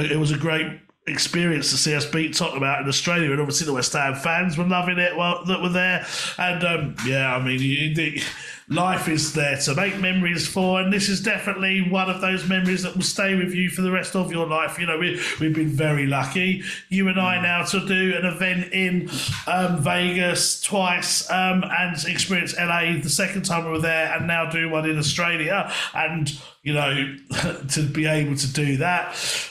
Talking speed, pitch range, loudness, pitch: 210 wpm, 150-185 Hz, -22 LUFS, 170 Hz